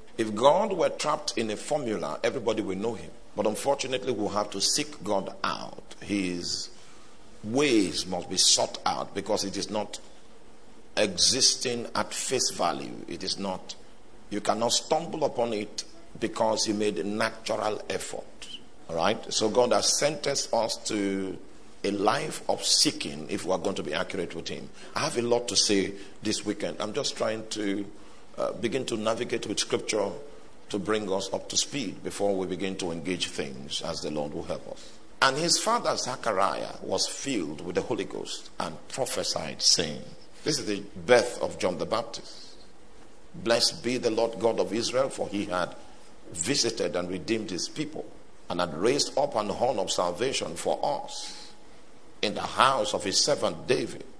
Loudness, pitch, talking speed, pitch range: -28 LUFS, 105 Hz, 175 wpm, 95-115 Hz